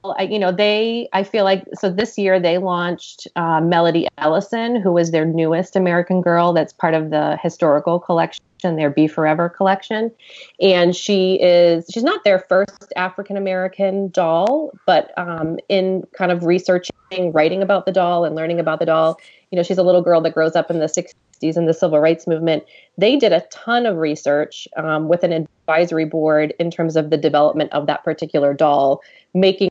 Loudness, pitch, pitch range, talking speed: -17 LUFS, 175 Hz, 160-190 Hz, 190 wpm